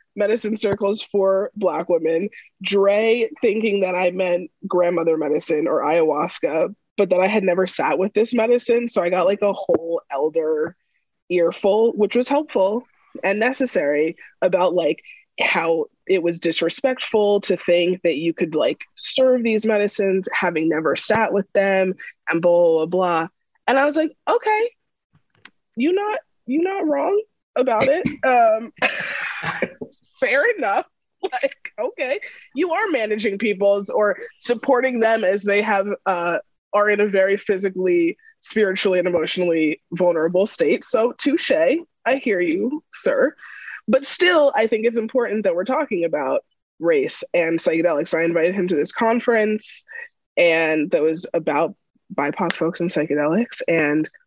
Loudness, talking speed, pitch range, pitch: -20 LUFS, 145 wpm, 180-260 Hz, 205 Hz